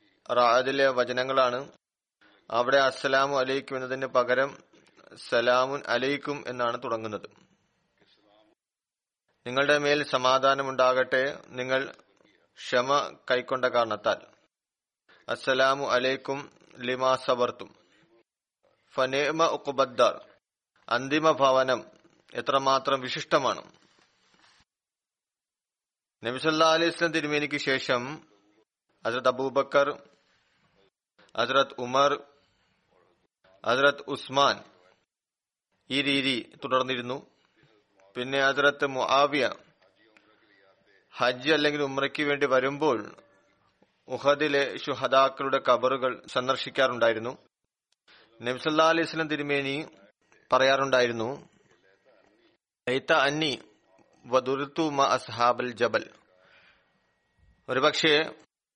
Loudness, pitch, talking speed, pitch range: -26 LUFS, 135 Hz, 55 wpm, 125-145 Hz